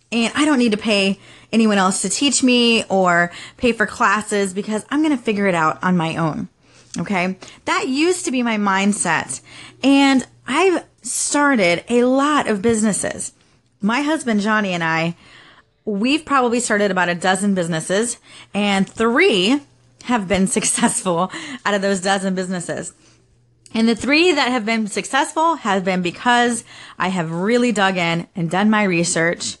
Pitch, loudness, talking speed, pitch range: 210 Hz, -18 LUFS, 160 wpm, 185-245 Hz